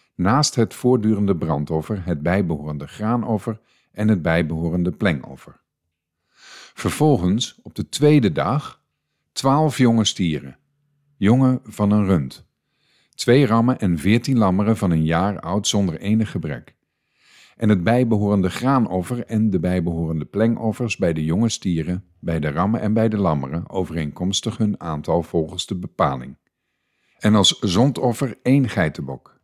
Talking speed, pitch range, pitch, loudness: 130 wpm, 85-115 Hz, 100 Hz, -20 LUFS